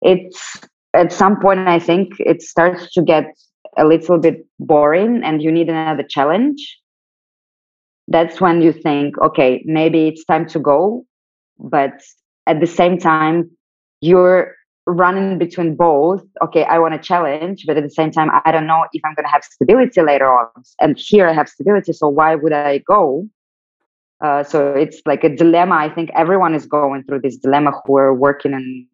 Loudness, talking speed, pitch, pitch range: -14 LUFS, 180 wpm, 160 Hz, 145-175 Hz